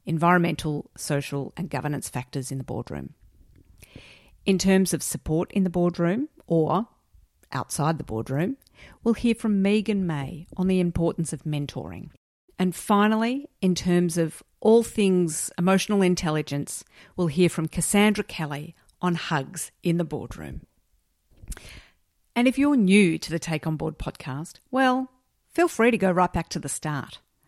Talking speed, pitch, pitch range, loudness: 150 wpm, 170 Hz, 145-195 Hz, -25 LUFS